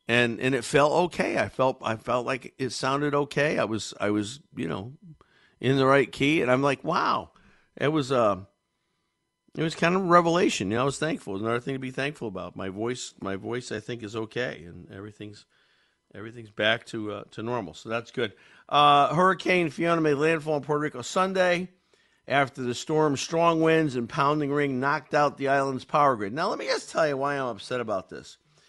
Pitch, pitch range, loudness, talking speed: 135 Hz, 115-150 Hz, -26 LUFS, 215 wpm